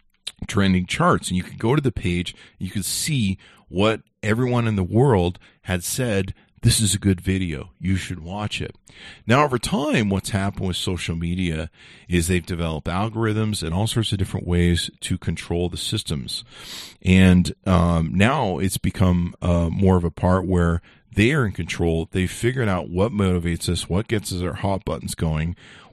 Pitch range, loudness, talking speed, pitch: 85-105 Hz, -22 LUFS, 190 wpm, 95 Hz